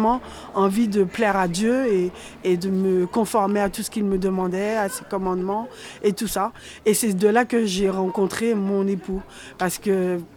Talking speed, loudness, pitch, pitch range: 190 wpm, -22 LUFS, 200 Hz, 190-220 Hz